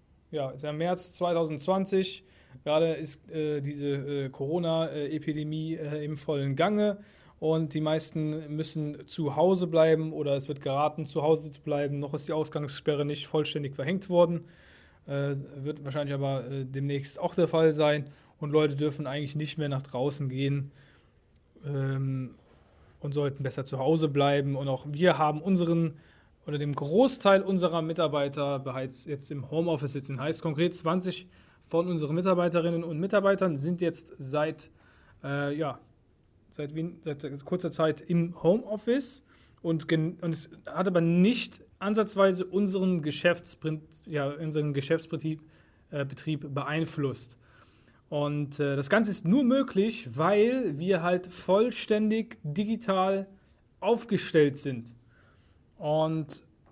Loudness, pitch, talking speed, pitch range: -29 LUFS, 155 Hz, 135 wpm, 145-175 Hz